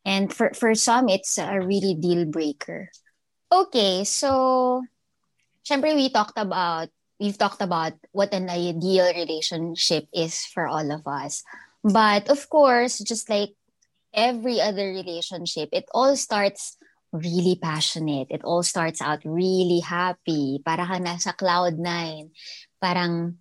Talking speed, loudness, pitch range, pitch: 130 wpm, -23 LUFS, 170-215 Hz, 180 Hz